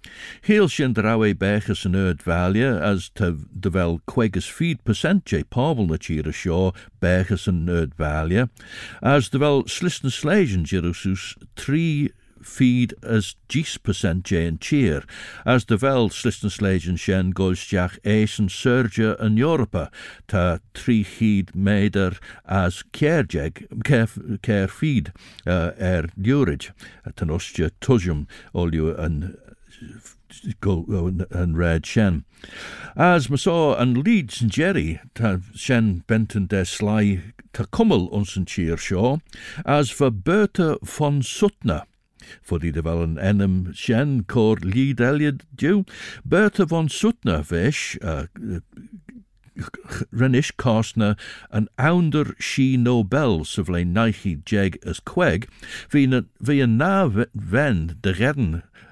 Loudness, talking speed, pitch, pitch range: -22 LUFS, 115 wpm, 105 Hz, 90-130 Hz